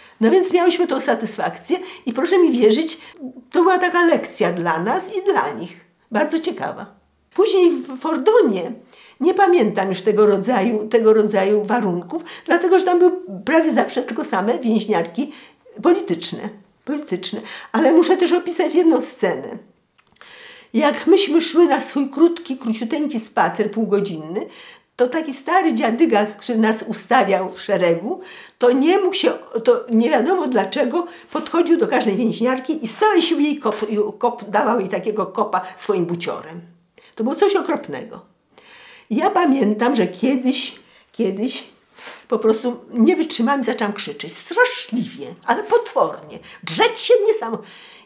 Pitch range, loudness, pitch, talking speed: 215-350 Hz, -18 LUFS, 260 Hz, 140 wpm